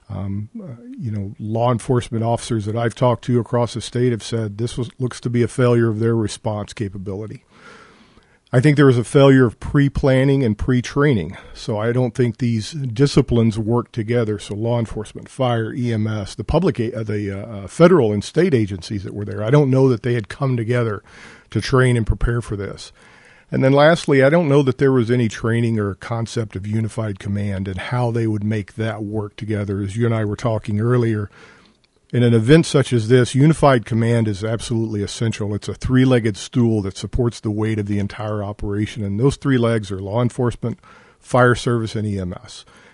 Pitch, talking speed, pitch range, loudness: 115 Hz, 200 wpm, 105-125 Hz, -19 LUFS